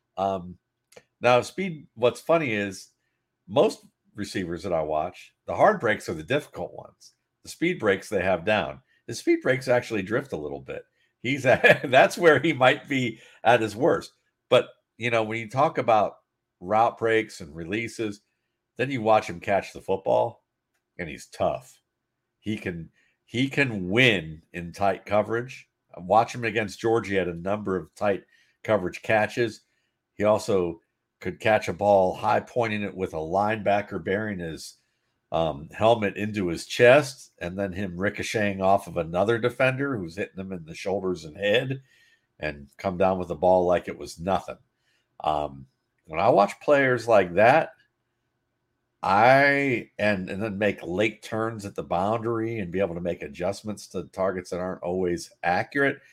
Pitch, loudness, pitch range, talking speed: 105 Hz, -25 LUFS, 95-120 Hz, 165 wpm